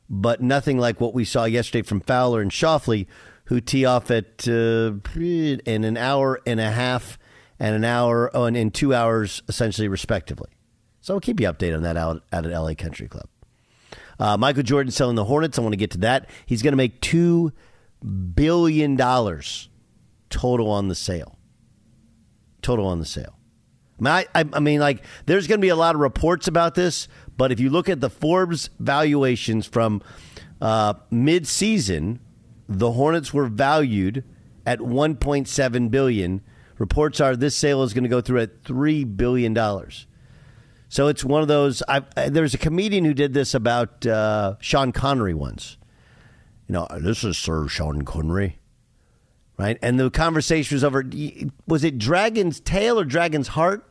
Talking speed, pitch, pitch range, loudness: 170 wpm, 125 Hz, 110-145 Hz, -21 LUFS